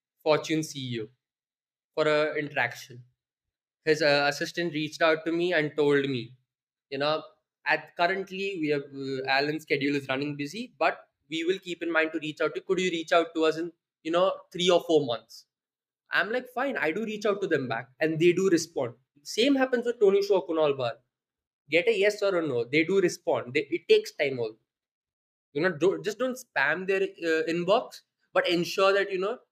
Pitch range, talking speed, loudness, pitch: 145-195 Hz, 200 wpm, -27 LUFS, 165 Hz